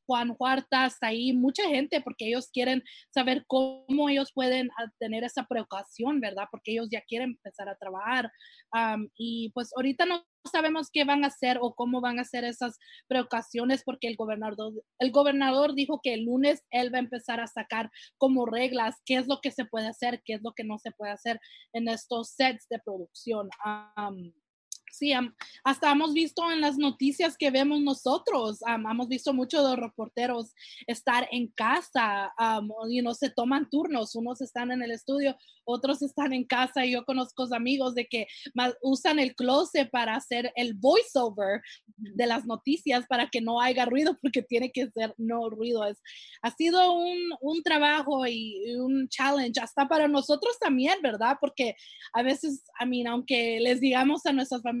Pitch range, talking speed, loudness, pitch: 230-275 Hz, 180 wpm, -28 LUFS, 250 Hz